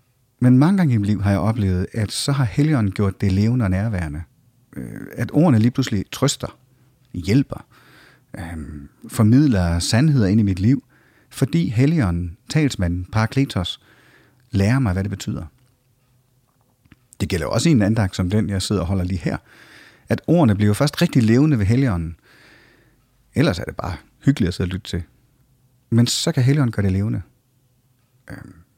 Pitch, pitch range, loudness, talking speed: 115 Hz, 100-130 Hz, -19 LUFS, 165 wpm